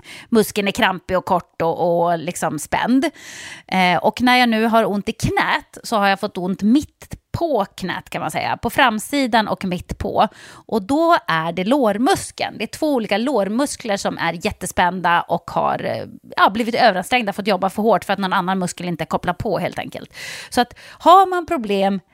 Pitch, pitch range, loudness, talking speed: 205 Hz, 185-245 Hz, -19 LUFS, 190 wpm